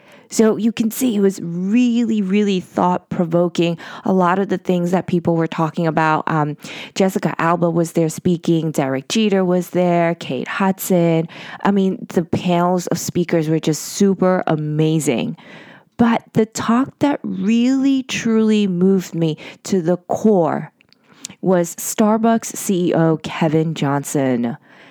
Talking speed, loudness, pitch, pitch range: 140 wpm, -18 LUFS, 180 Hz, 165-215 Hz